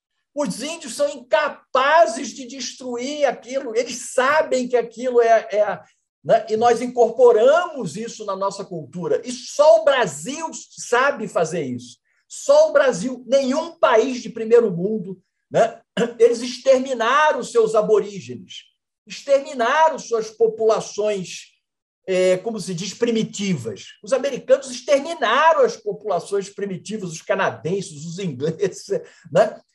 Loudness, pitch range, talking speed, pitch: -20 LUFS, 205-280 Hz, 125 wpm, 235 Hz